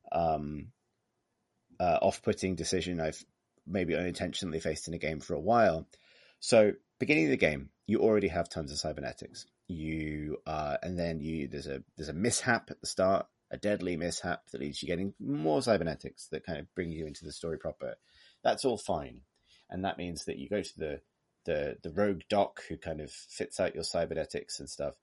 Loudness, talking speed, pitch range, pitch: -33 LUFS, 190 wpm, 75-90 Hz, 80 Hz